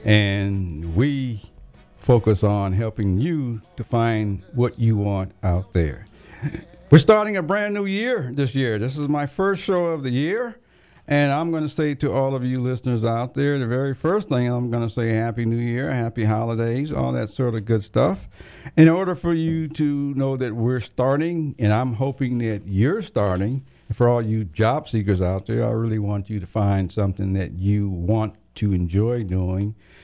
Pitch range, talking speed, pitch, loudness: 105-140 Hz, 190 wpm, 120 Hz, -22 LUFS